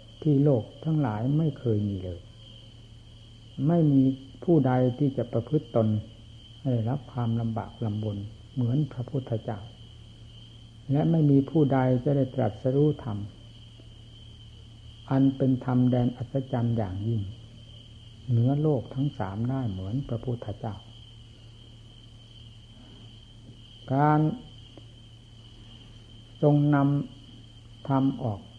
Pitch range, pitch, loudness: 115-135 Hz, 115 Hz, -27 LUFS